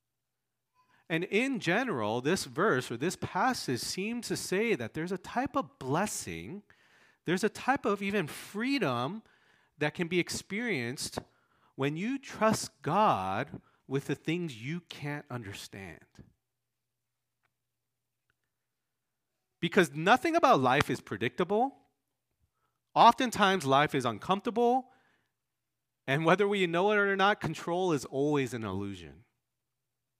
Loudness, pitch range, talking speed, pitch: -30 LUFS, 125-205 Hz, 115 wpm, 160 Hz